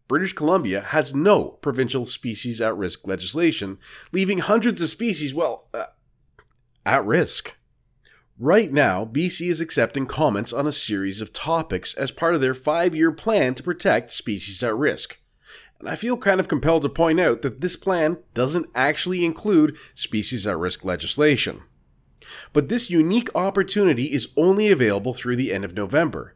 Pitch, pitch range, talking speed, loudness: 150 Hz, 120-180 Hz, 160 wpm, -22 LUFS